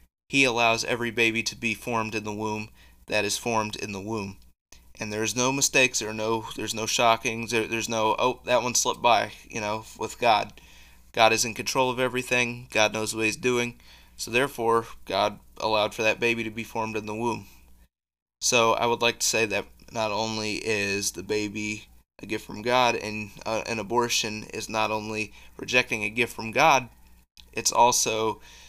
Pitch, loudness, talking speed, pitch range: 110 Hz, -25 LUFS, 195 wpm, 105-120 Hz